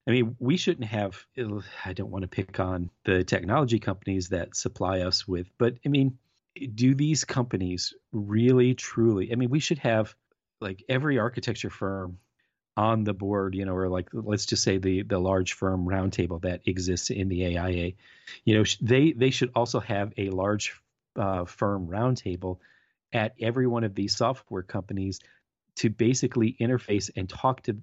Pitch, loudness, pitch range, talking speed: 105 Hz, -27 LUFS, 95-120 Hz, 170 wpm